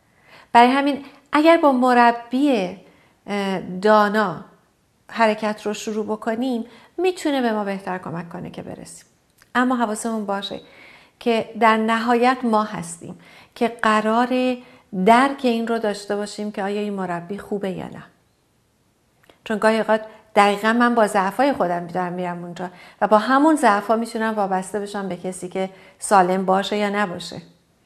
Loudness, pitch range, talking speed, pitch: -20 LUFS, 195-235 Hz, 140 wpm, 215 Hz